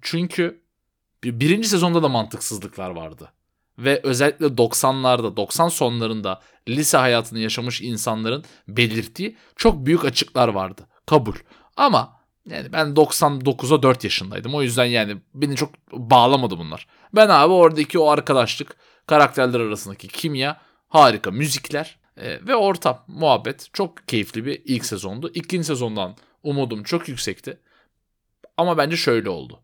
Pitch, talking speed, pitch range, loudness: 135 Hz, 125 wpm, 115-155 Hz, -19 LUFS